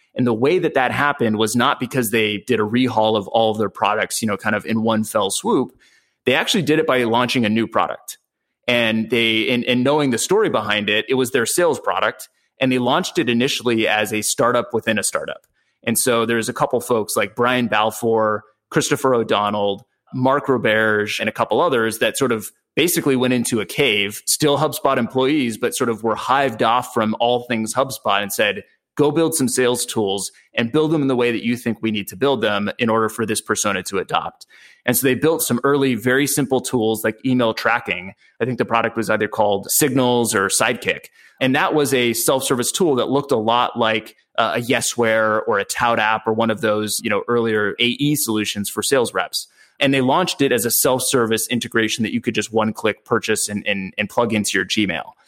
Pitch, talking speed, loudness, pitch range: 120 Hz, 215 wpm, -19 LUFS, 110-130 Hz